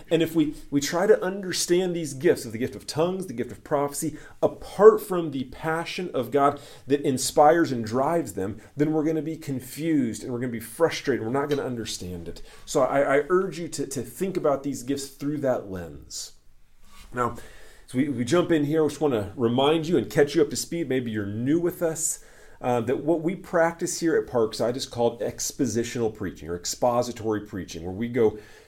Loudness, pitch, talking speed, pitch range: -25 LUFS, 140 Hz, 220 wpm, 115-160 Hz